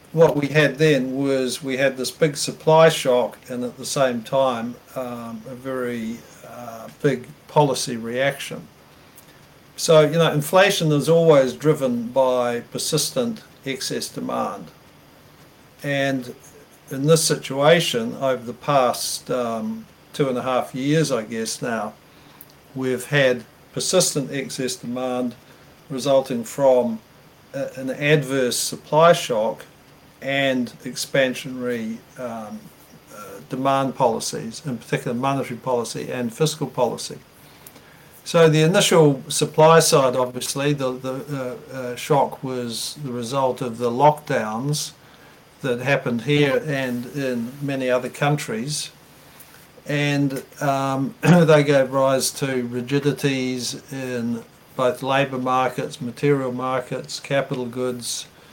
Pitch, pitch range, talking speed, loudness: 135 Hz, 125-145 Hz, 120 wpm, -21 LUFS